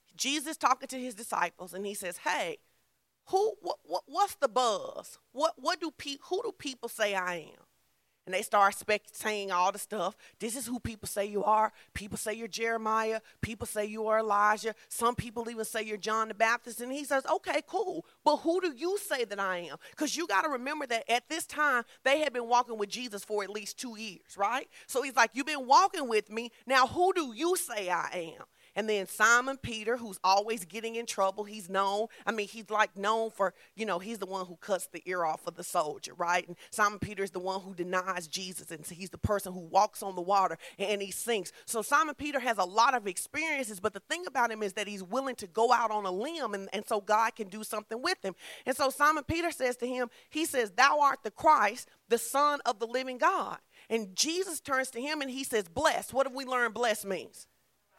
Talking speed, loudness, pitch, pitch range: 230 wpm, -31 LUFS, 225 Hz, 200-270 Hz